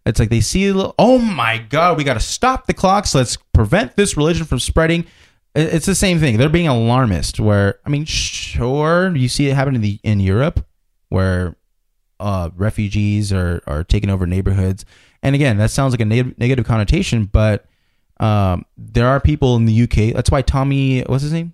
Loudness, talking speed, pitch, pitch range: -16 LUFS, 200 wpm, 115 Hz, 100-145 Hz